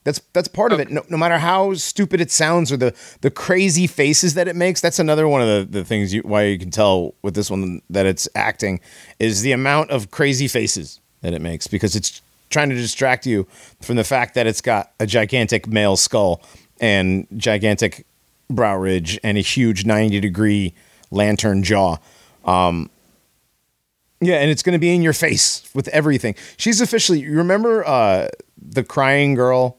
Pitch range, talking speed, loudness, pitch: 105-155 Hz, 185 wpm, -18 LUFS, 120 Hz